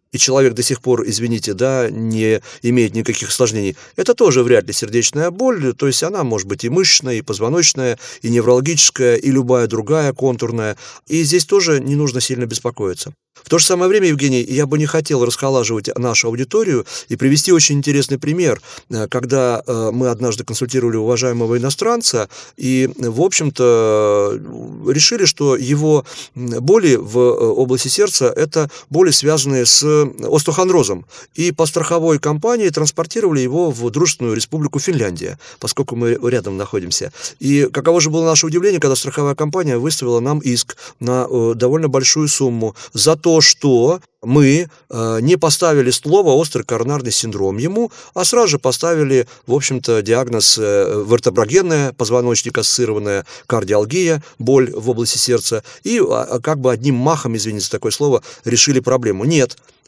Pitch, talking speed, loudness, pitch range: 130 Hz, 150 wpm, -15 LUFS, 120-155 Hz